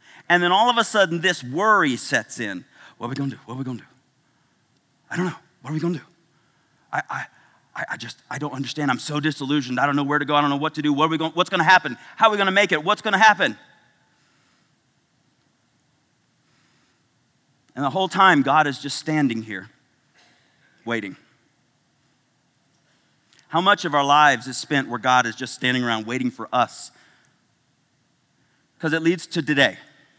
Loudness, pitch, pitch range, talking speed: -21 LUFS, 145 Hz, 135-165 Hz, 205 wpm